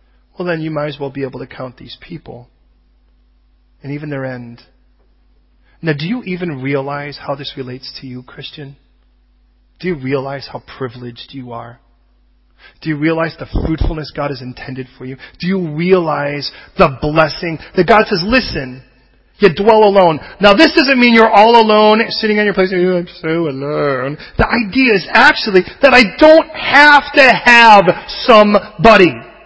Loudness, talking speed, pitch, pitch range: -11 LUFS, 170 wpm, 150 Hz, 130-205 Hz